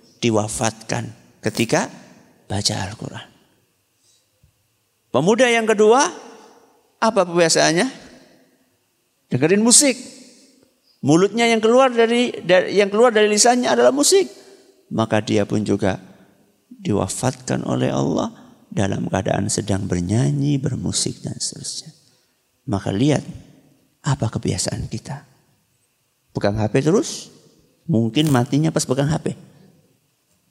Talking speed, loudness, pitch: 95 wpm, -19 LUFS, 130 Hz